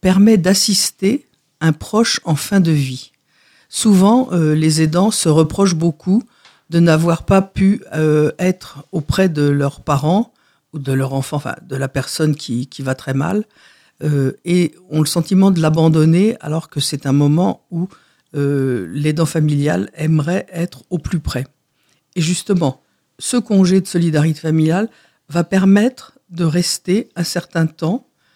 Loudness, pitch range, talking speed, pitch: -16 LUFS, 150-190 Hz, 155 wpm, 165 Hz